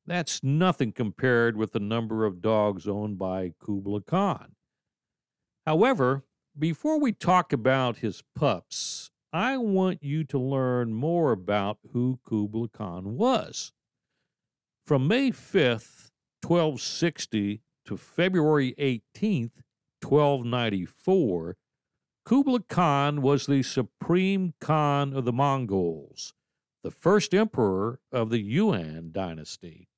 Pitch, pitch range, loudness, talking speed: 135 Hz, 110-165 Hz, -26 LUFS, 110 wpm